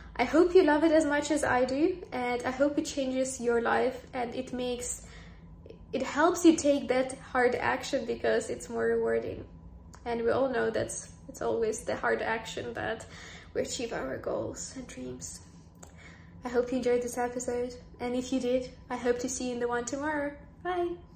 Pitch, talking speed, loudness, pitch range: 250 Hz, 195 wpm, -30 LUFS, 230-280 Hz